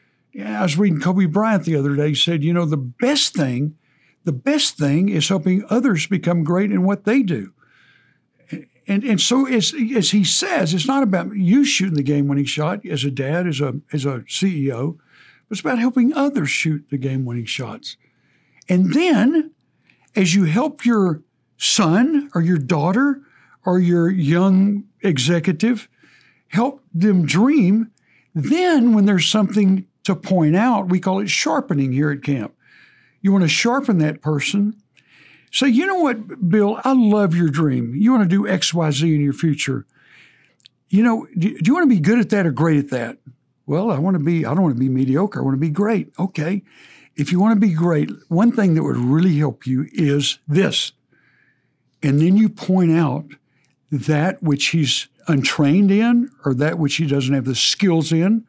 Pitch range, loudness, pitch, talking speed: 150-210 Hz, -18 LUFS, 180 Hz, 185 wpm